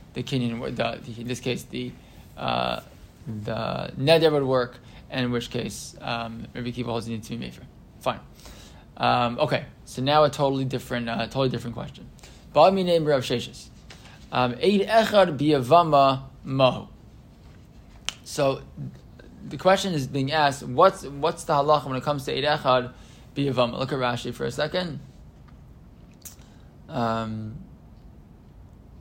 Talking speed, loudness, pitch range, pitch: 130 wpm, -24 LUFS, 115-145 Hz, 125 Hz